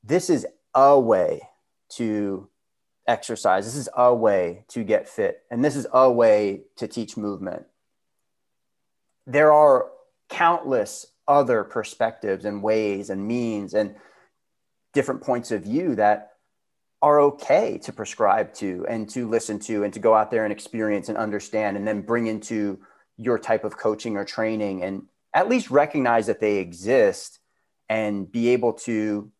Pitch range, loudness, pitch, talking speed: 105-125 Hz, -22 LUFS, 110 Hz, 155 wpm